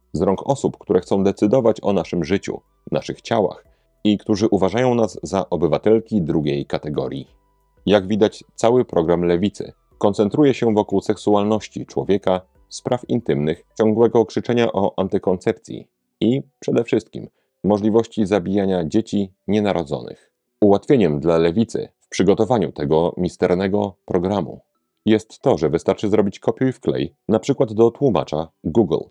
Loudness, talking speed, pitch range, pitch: -20 LUFS, 130 wpm, 90-110 Hz, 100 Hz